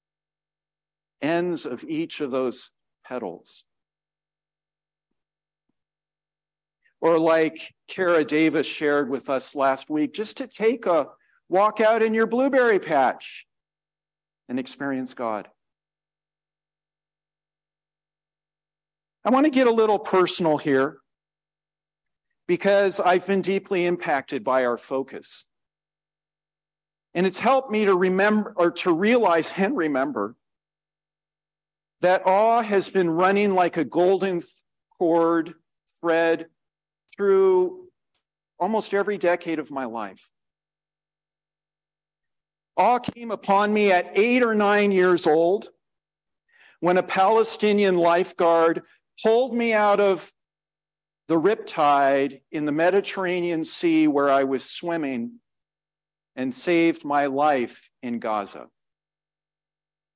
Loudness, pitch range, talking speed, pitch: -22 LUFS, 155-200 Hz, 105 wpm, 165 Hz